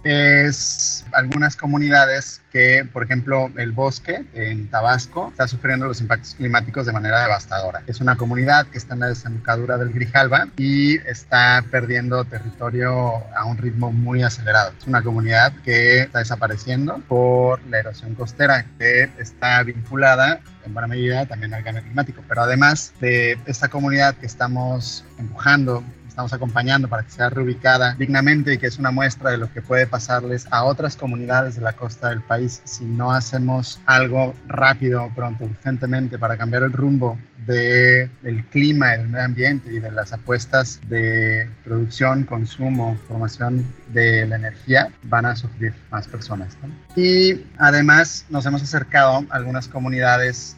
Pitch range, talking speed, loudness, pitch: 115-135 Hz, 155 wpm, -18 LUFS, 125 Hz